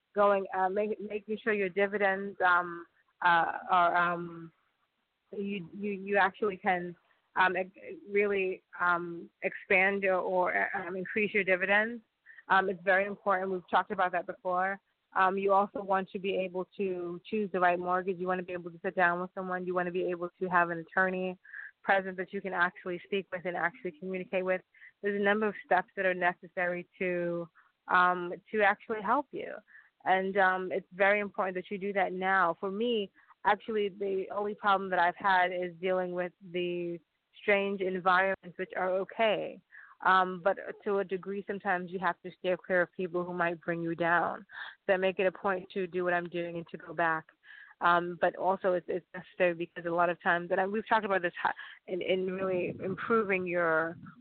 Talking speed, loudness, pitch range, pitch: 190 wpm, -31 LUFS, 180-195 Hz, 185 Hz